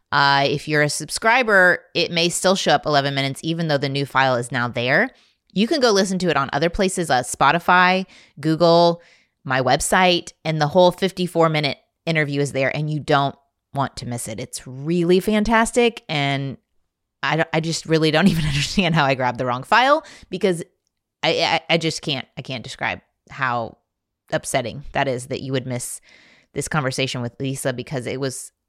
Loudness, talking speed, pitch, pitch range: -20 LUFS, 190 wpm, 150 Hz, 135-175 Hz